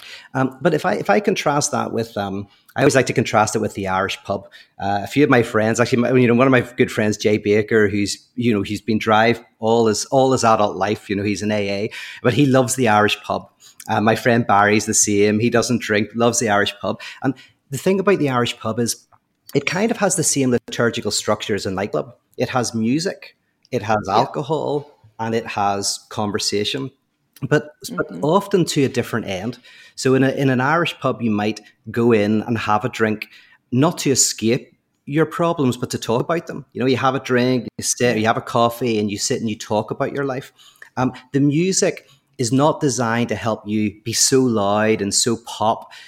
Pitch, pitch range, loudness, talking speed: 120 Hz, 105-130 Hz, -19 LUFS, 220 wpm